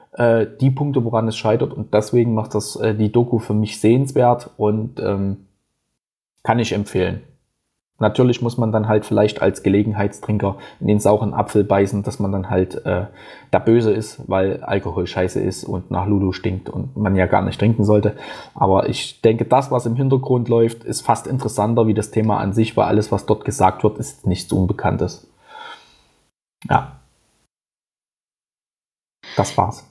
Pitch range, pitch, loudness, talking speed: 100-120 Hz, 110 Hz, -19 LUFS, 165 wpm